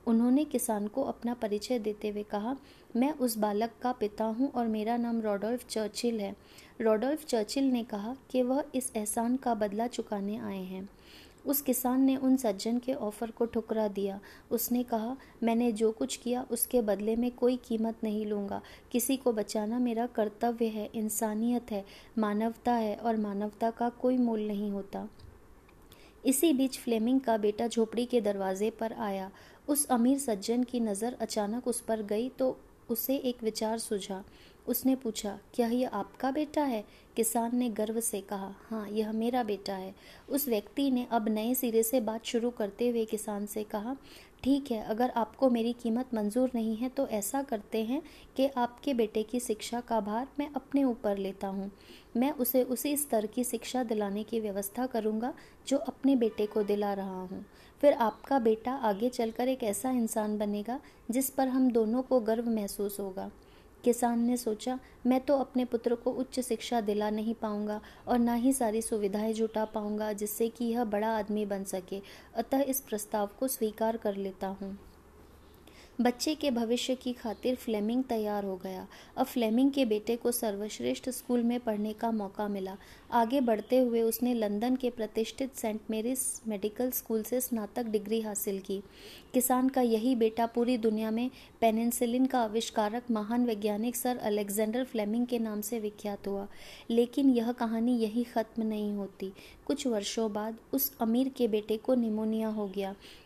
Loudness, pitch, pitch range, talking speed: -31 LUFS, 230 Hz, 215-245 Hz, 175 wpm